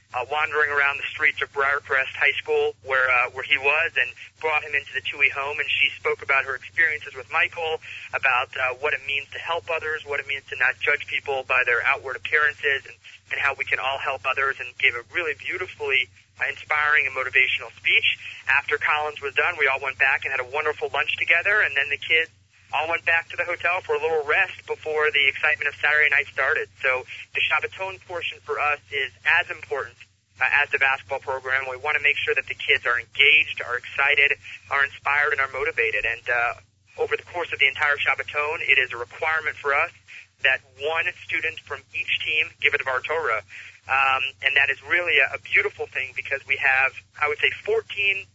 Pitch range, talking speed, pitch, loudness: 135-165 Hz, 215 wpm, 150 Hz, -22 LUFS